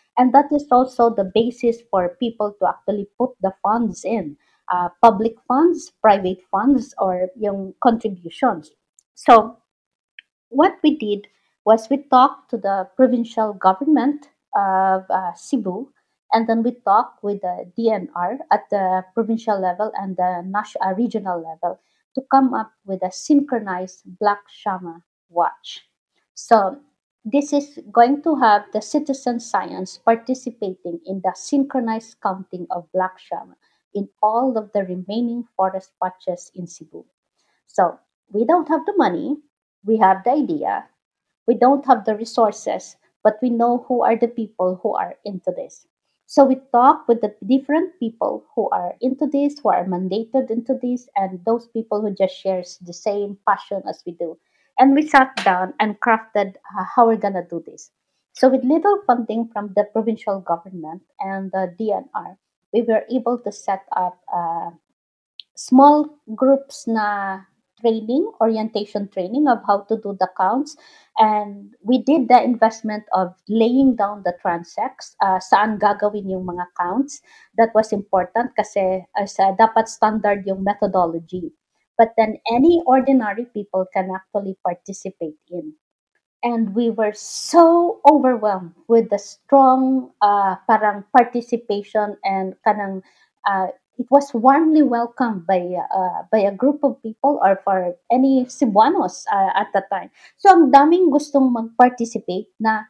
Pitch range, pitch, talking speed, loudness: 195-255 Hz, 220 Hz, 150 wpm, -19 LUFS